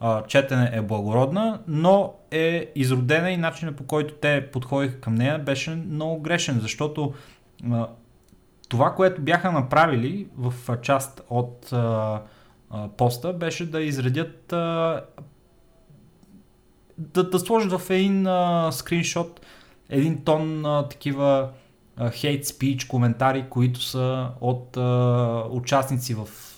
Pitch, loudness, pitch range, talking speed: 140 Hz, -24 LUFS, 125-165 Hz, 105 wpm